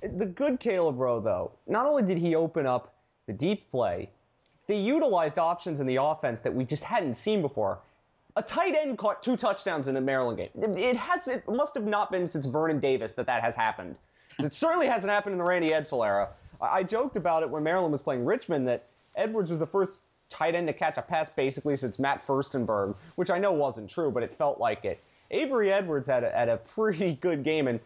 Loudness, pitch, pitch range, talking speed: -29 LUFS, 175 Hz, 140-215 Hz, 225 wpm